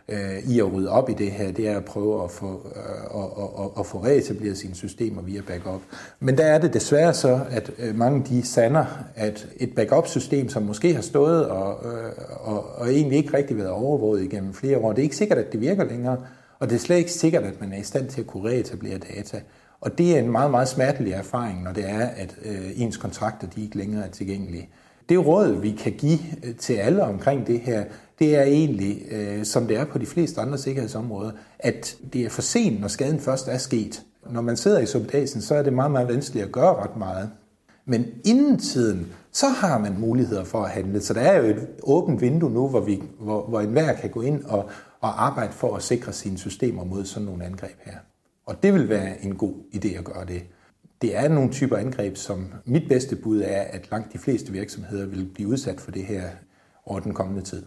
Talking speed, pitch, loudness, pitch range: 220 wpm, 110 Hz, -24 LUFS, 100-130 Hz